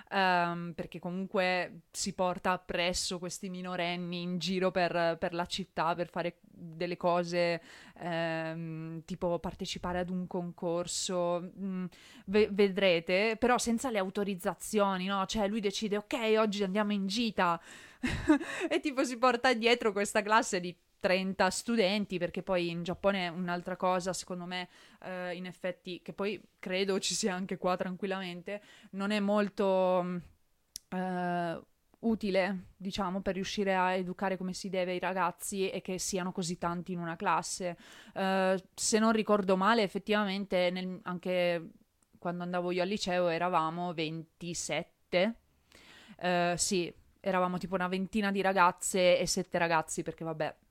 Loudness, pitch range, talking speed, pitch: -32 LUFS, 175-200 Hz, 145 wpm, 185 Hz